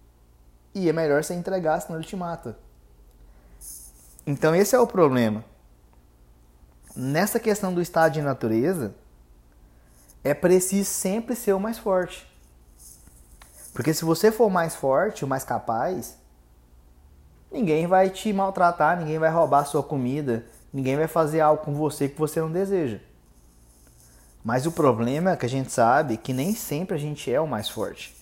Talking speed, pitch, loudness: 155 wpm, 135 Hz, -24 LUFS